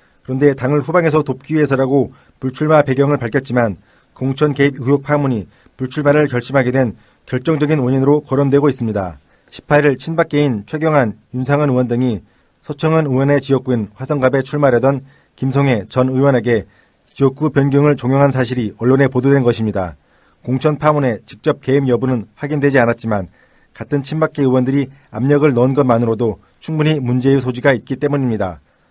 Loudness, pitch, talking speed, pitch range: -16 LUFS, 135 Hz, 370 characters per minute, 120-145 Hz